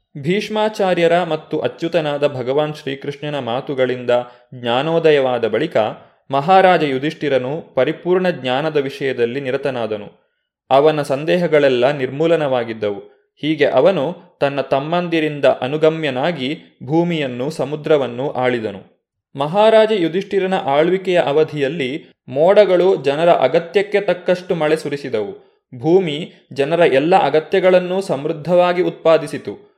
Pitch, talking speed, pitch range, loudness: 155 Hz, 85 wpm, 135-180 Hz, -17 LUFS